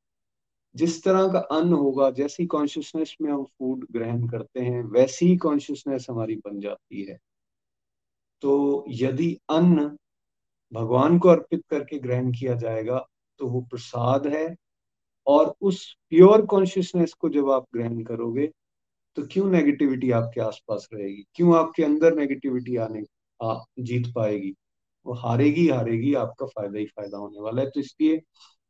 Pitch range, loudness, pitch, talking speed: 115-160 Hz, -23 LUFS, 135 Hz, 140 wpm